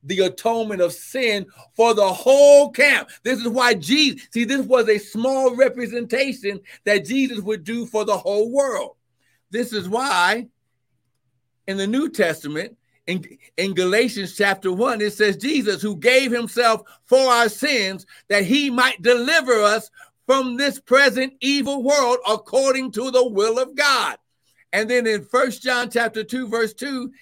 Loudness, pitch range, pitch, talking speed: -19 LUFS, 205-260 Hz, 235 Hz, 160 wpm